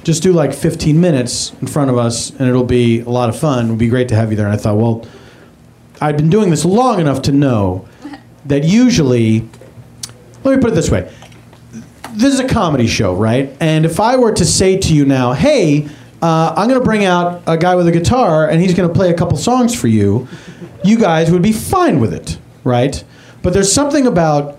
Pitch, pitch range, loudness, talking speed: 150 Hz, 120-180 Hz, -13 LUFS, 225 wpm